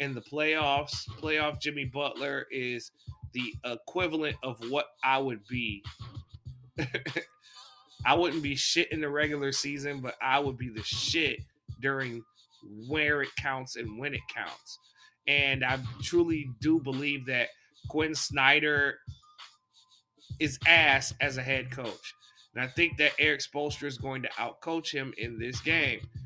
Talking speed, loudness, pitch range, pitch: 145 wpm, -29 LUFS, 125-150 Hz, 135 Hz